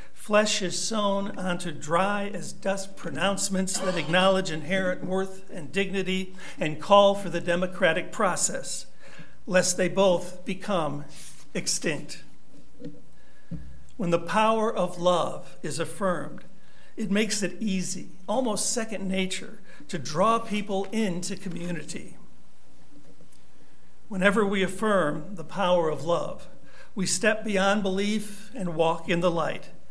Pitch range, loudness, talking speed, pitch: 175-200 Hz, -26 LUFS, 120 wpm, 190 Hz